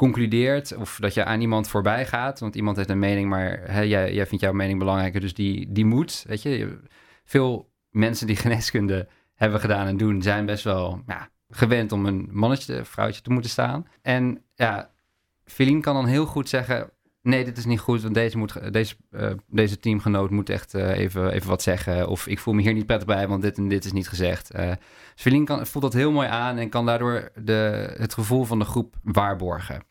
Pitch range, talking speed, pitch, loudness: 100-120 Hz, 215 wpm, 110 Hz, -24 LUFS